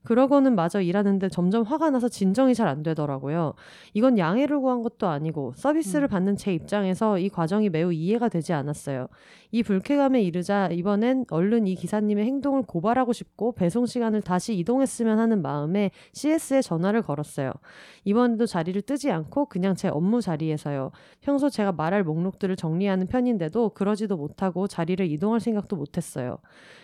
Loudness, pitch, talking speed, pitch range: -25 LUFS, 200 Hz, 395 characters per minute, 170-235 Hz